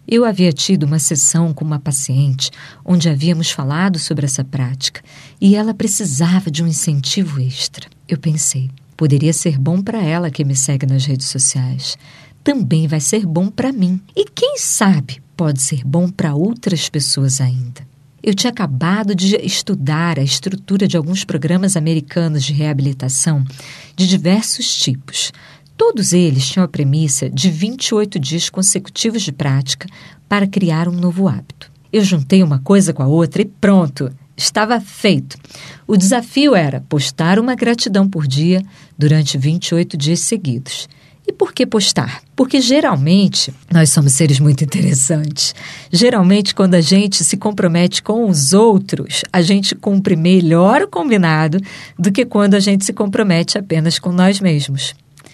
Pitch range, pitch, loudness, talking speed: 145-195 Hz, 165 Hz, -14 LUFS, 155 wpm